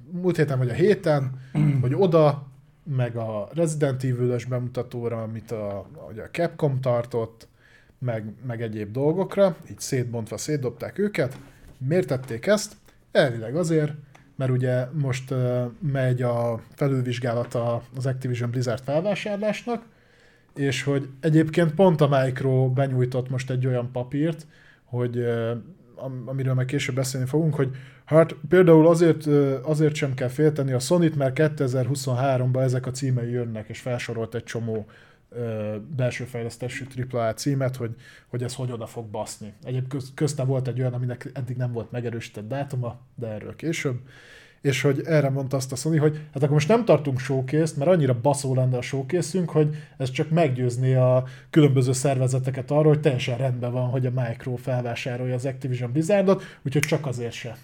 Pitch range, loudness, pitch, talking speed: 125-150 Hz, -24 LUFS, 130 Hz, 155 wpm